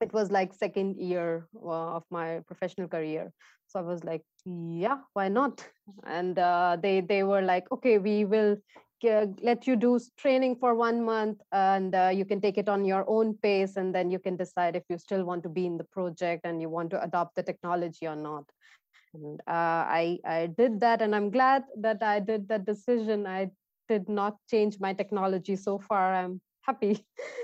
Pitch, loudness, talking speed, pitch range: 195 Hz, -29 LUFS, 195 wpm, 175-215 Hz